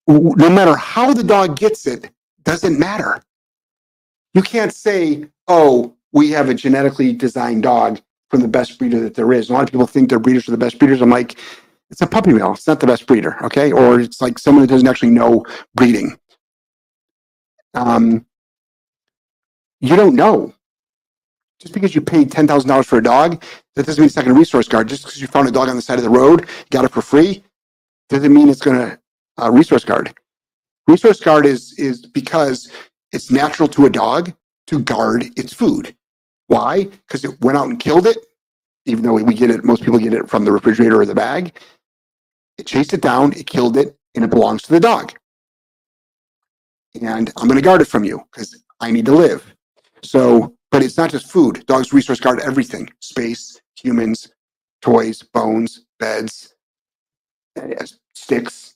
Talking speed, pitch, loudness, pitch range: 185 wpm, 135 Hz, -14 LUFS, 120-155 Hz